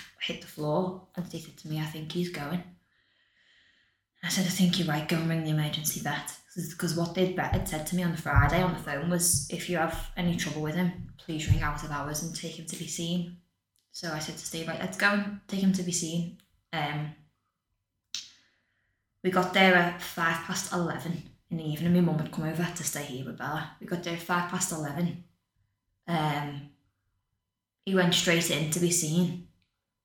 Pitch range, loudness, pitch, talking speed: 150-175 Hz, -29 LUFS, 165 Hz, 210 wpm